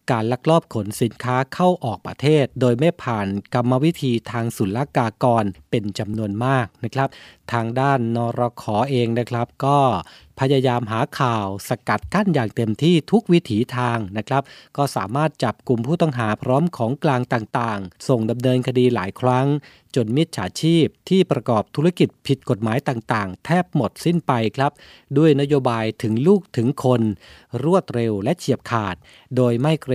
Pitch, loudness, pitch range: 125 Hz, -21 LUFS, 115-145 Hz